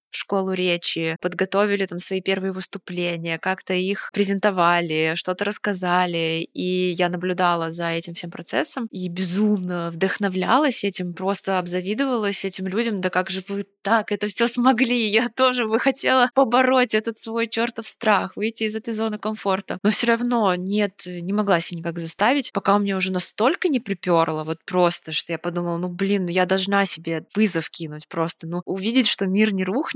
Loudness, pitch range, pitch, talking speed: -22 LUFS, 175-215 Hz, 190 Hz, 170 wpm